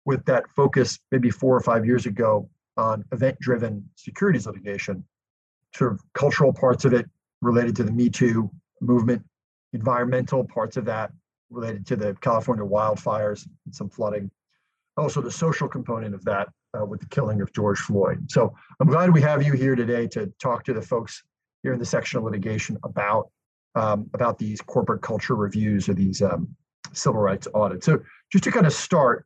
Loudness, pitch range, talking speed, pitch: -23 LUFS, 105-135 Hz, 180 wpm, 120 Hz